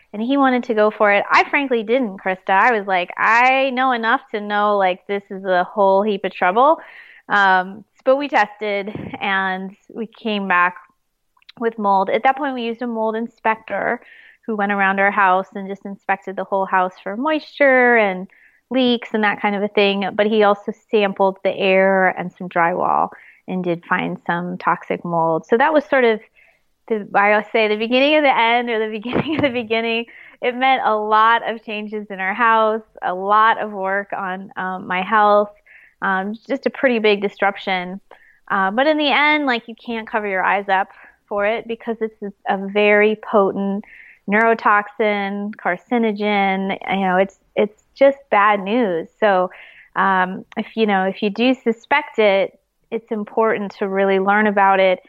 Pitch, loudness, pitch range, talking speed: 210 Hz, -18 LUFS, 195-230 Hz, 185 wpm